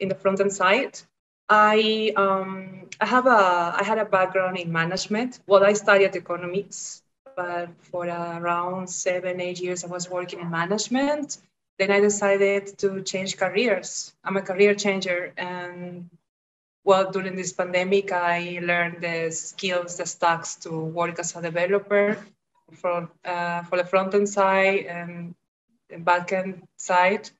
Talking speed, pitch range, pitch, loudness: 155 wpm, 175-200 Hz, 185 Hz, -23 LUFS